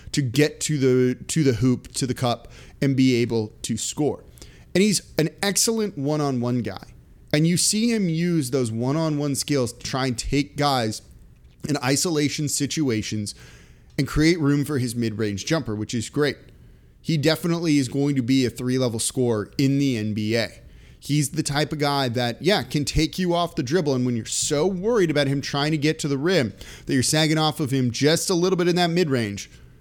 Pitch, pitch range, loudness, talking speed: 140 Hz, 120-155 Hz, -22 LUFS, 195 wpm